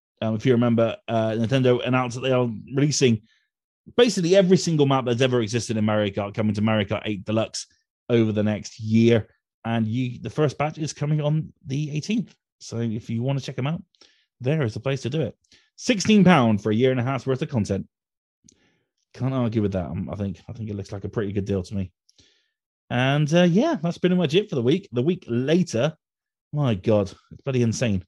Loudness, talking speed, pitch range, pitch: -23 LUFS, 225 wpm, 110-145 Hz, 125 Hz